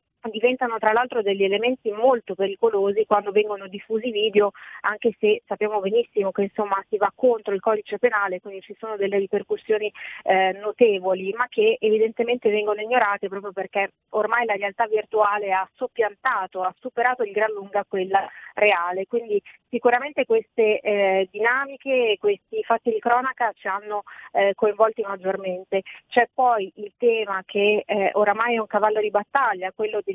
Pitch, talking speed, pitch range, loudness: 210 Hz, 155 wpm, 200-235 Hz, -23 LUFS